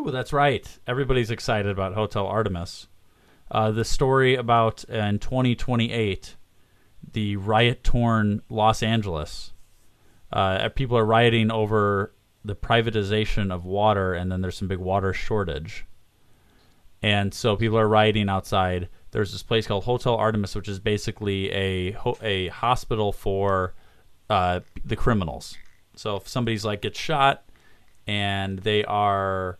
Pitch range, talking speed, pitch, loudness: 95-115 Hz, 145 wpm, 105 Hz, -24 LUFS